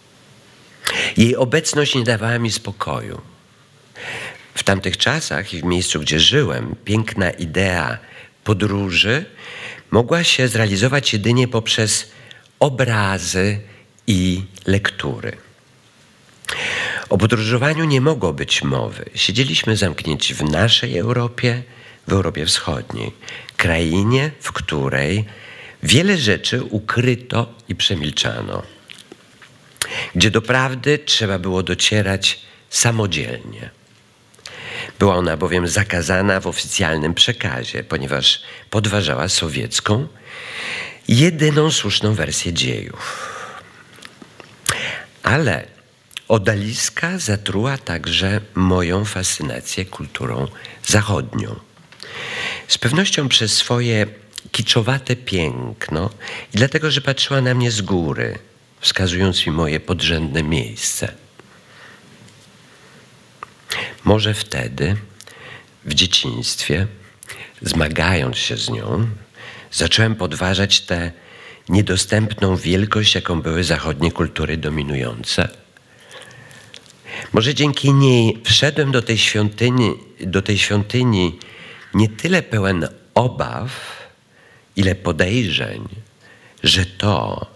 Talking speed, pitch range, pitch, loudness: 90 wpm, 90-120 Hz, 105 Hz, -18 LUFS